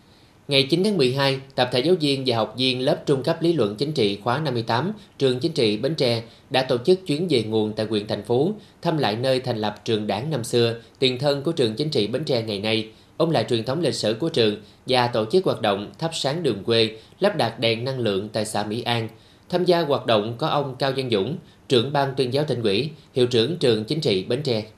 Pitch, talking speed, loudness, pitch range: 125 Hz, 245 wpm, -22 LUFS, 110-145 Hz